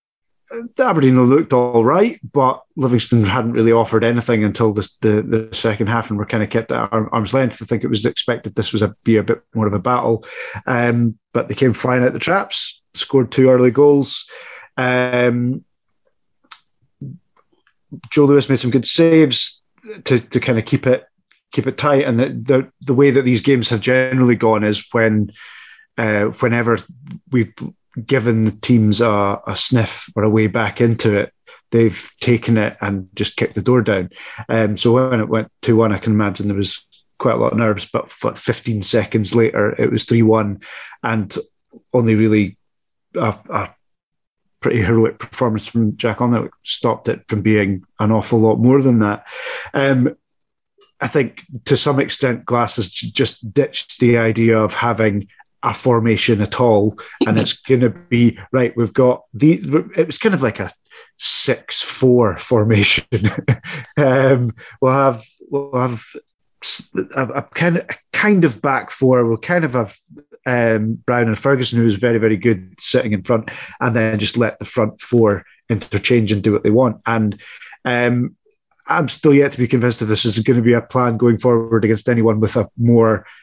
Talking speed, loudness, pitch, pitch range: 180 wpm, -16 LUFS, 120 Hz, 110-130 Hz